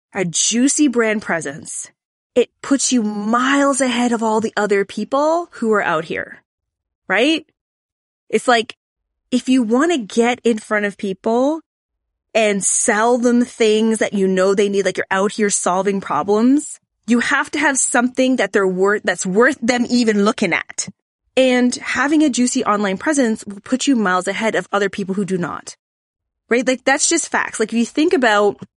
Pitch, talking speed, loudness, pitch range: 230 Hz, 180 wpm, -17 LUFS, 205-255 Hz